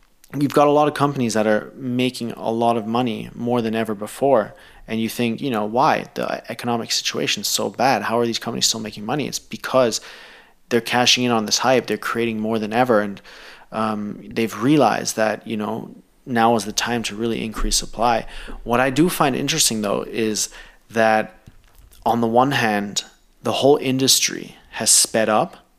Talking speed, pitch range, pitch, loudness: 190 wpm, 110-125 Hz, 115 Hz, -20 LUFS